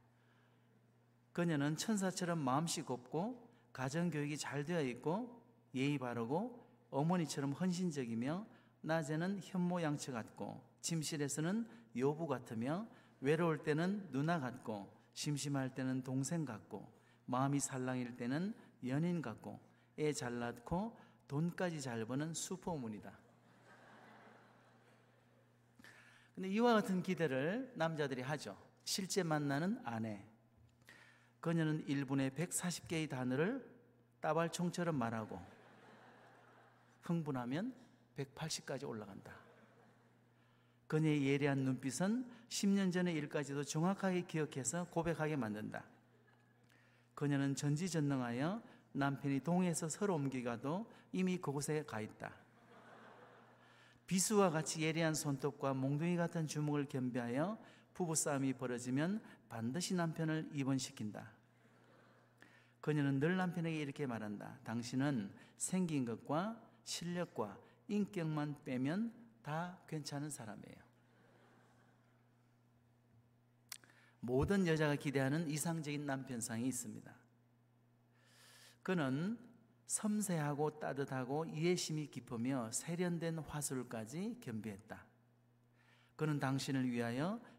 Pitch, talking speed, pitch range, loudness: 145 Hz, 240 characters per minute, 125-170 Hz, -40 LUFS